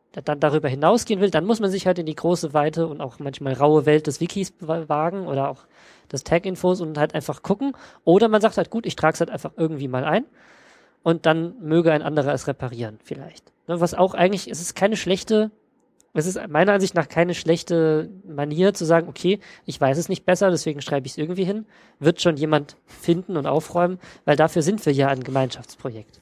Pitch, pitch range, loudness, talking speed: 165 Hz, 150-185 Hz, -22 LUFS, 210 wpm